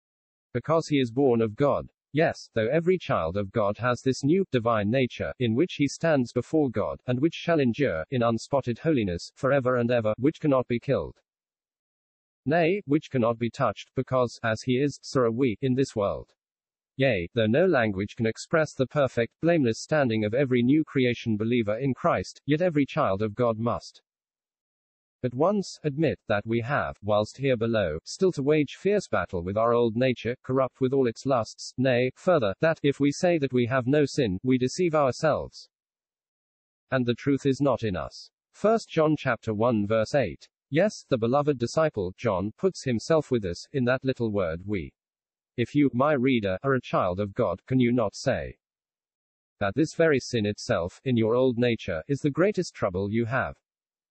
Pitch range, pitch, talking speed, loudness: 110-145 Hz, 125 Hz, 185 wpm, -26 LUFS